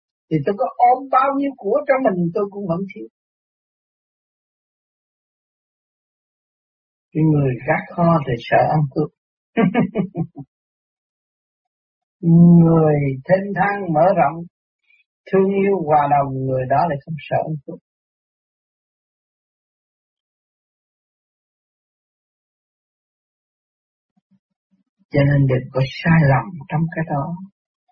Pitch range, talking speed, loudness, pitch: 150-195 Hz, 95 wpm, -18 LUFS, 170 Hz